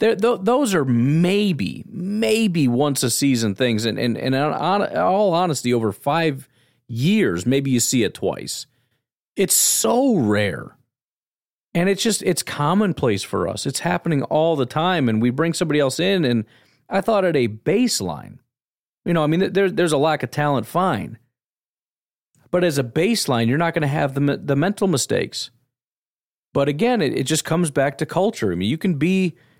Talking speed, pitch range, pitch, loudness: 175 wpm, 130-185 Hz, 155 Hz, -20 LUFS